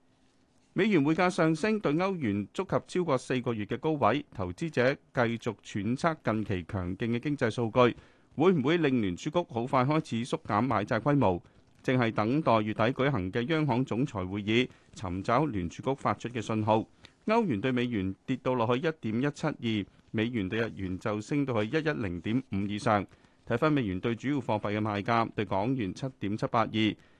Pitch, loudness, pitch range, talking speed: 120 Hz, -30 LUFS, 105-135 Hz, 280 characters per minute